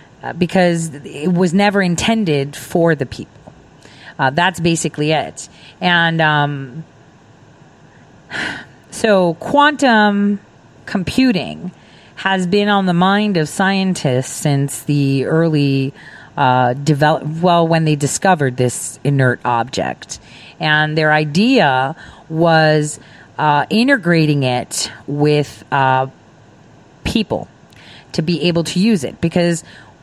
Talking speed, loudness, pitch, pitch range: 105 wpm, -15 LUFS, 160 Hz, 140-180 Hz